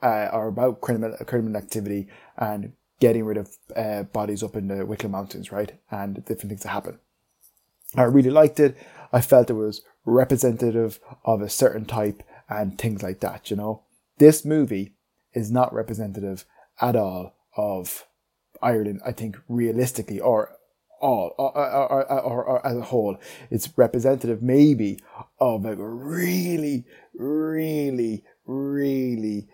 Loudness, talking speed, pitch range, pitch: -23 LUFS, 145 wpm, 105-130 Hz, 115 Hz